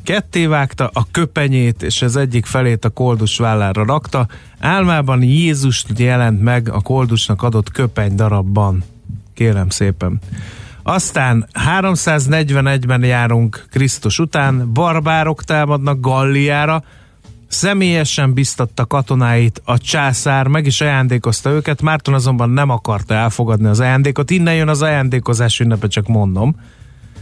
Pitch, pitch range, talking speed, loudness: 125 Hz, 115-145 Hz, 120 wpm, -14 LUFS